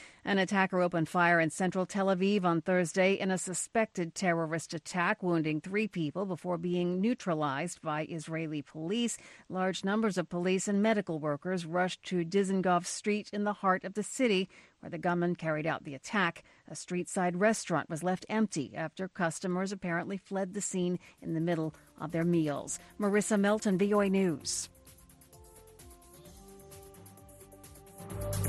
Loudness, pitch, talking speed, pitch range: -32 LUFS, 175 Hz, 145 wpm, 155-195 Hz